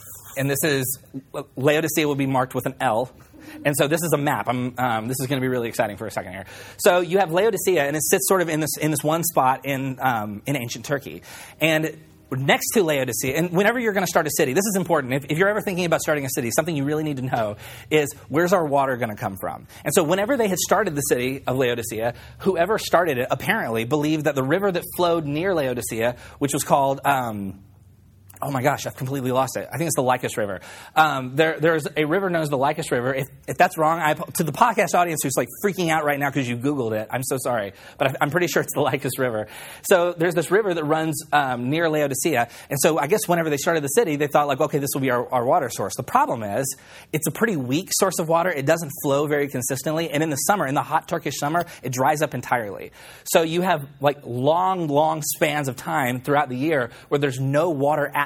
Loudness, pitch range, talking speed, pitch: -22 LUFS, 130-165 Hz, 245 wpm, 145 Hz